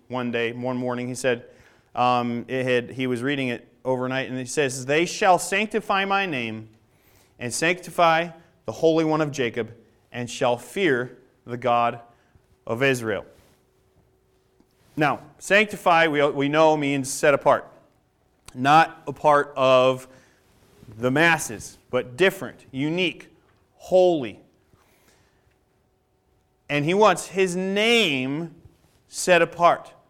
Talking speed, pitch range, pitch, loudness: 120 wpm, 120-165 Hz, 130 Hz, -22 LUFS